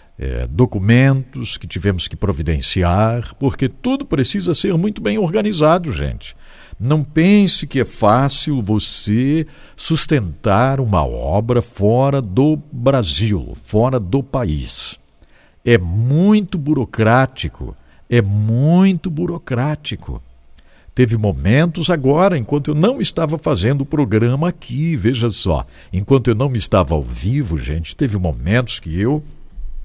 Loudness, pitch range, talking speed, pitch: -16 LUFS, 100-150 Hz, 120 wpm, 125 Hz